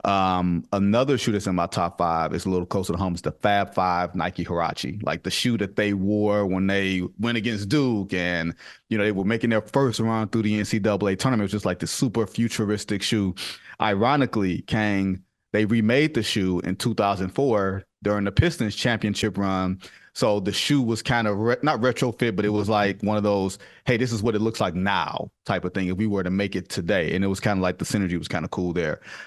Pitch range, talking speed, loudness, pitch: 95-110 Hz, 230 wpm, -24 LUFS, 100 Hz